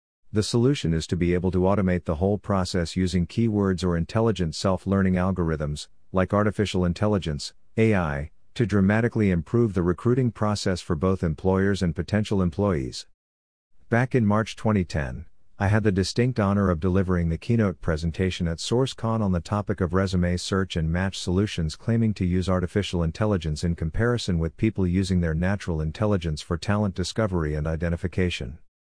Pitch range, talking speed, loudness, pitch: 85-105 Hz, 155 wpm, -25 LUFS, 95 Hz